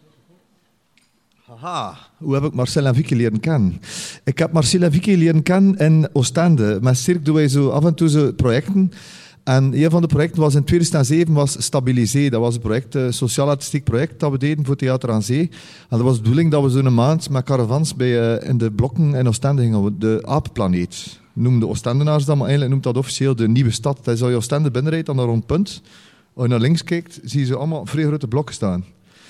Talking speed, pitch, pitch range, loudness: 215 wpm, 140 Hz, 120-155 Hz, -18 LUFS